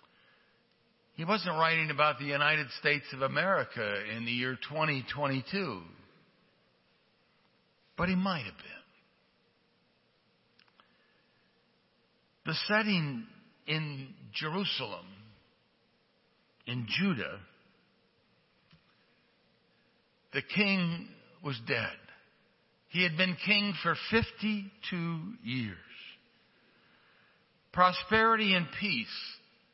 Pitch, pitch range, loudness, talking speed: 170 Hz, 135-195 Hz, -31 LUFS, 75 wpm